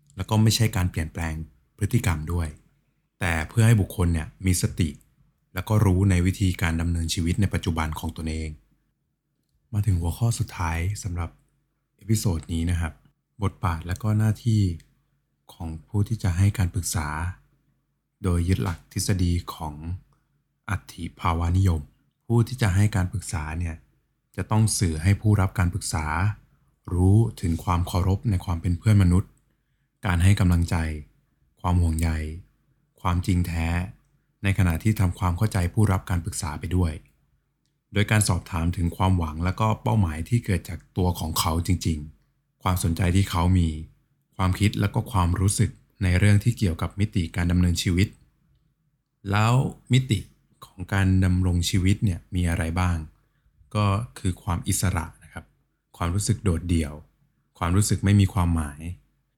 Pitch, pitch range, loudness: 95 Hz, 85-110 Hz, -25 LUFS